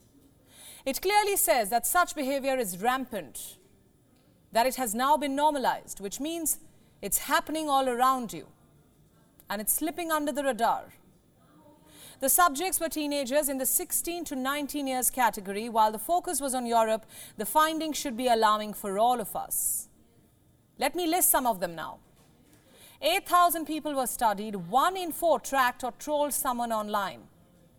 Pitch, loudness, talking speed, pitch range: 265 Hz, -27 LUFS, 155 wpm, 220-310 Hz